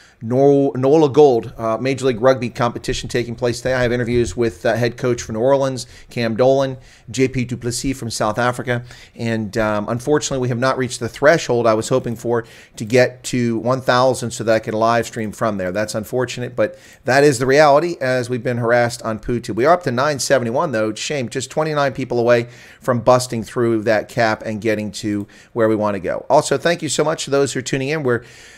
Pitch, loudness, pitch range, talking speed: 120 Hz, -18 LUFS, 115-130 Hz, 215 wpm